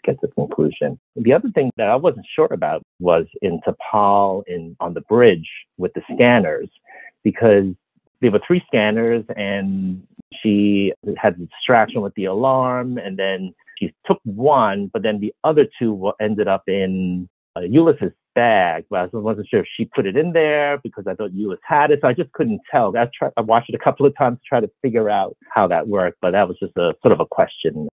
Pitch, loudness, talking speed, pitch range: 105 Hz, -18 LUFS, 210 wpm, 95-125 Hz